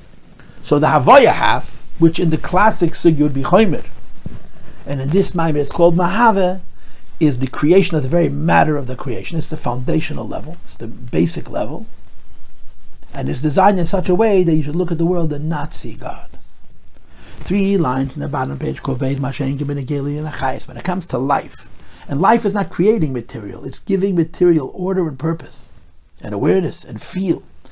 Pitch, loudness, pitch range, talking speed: 155 Hz, -17 LUFS, 135-175 Hz, 175 wpm